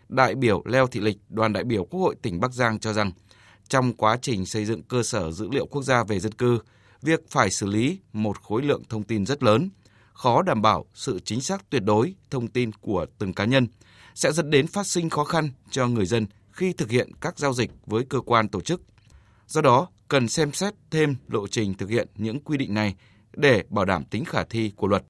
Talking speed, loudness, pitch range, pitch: 230 wpm, -24 LUFS, 105-135 Hz, 115 Hz